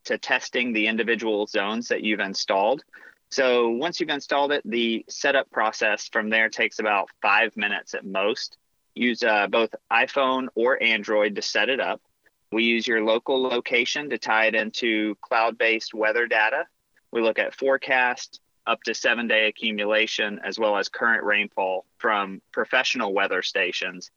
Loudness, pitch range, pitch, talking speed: -23 LUFS, 110-125 Hz, 115 Hz, 155 wpm